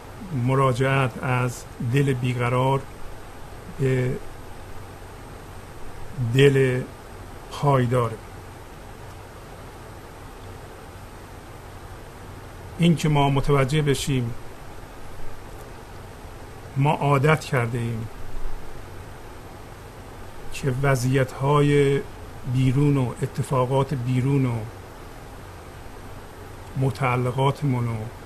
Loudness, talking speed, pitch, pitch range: -23 LUFS, 55 wpm, 115 Hz, 100-135 Hz